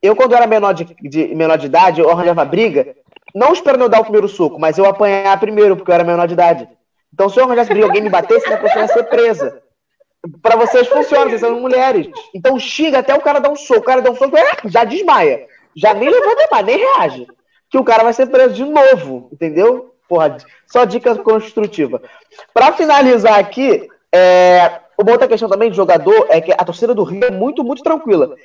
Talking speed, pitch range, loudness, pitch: 215 wpm, 195-285 Hz, -12 LUFS, 235 Hz